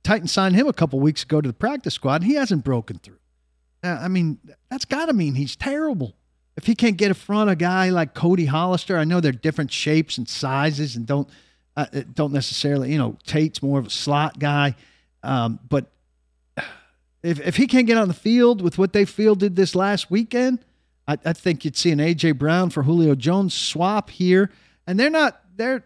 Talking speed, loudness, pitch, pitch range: 210 wpm, -21 LUFS, 160 Hz, 140-195 Hz